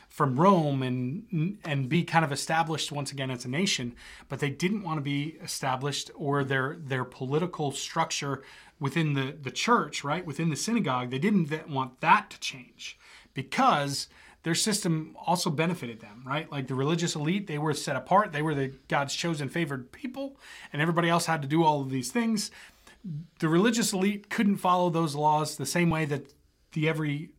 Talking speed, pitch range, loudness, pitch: 185 wpm, 140-170 Hz, -28 LUFS, 155 Hz